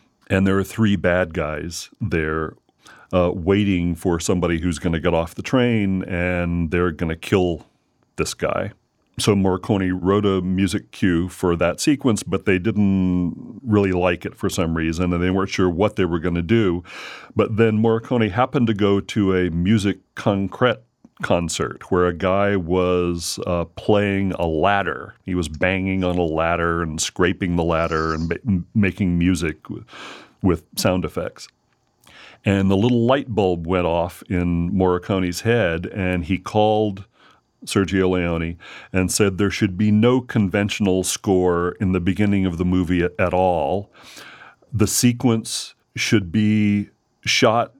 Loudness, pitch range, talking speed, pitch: -20 LUFS, 90-105 Hz, 160 wpm, 95 Hz